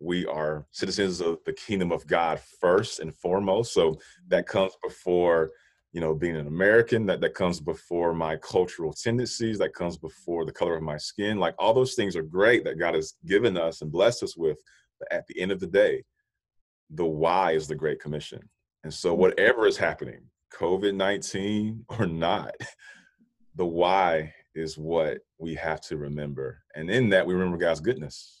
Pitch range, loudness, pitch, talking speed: 80-120 Hz, -26 LUFS, 90 Hz, 185 wpm